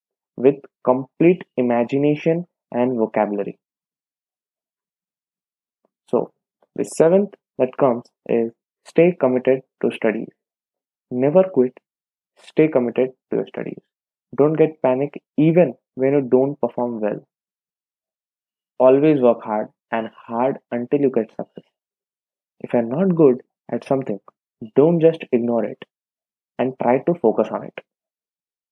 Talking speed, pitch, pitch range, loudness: 115 wpm, 130 Hz, 120-150 Hz, -20 LUFS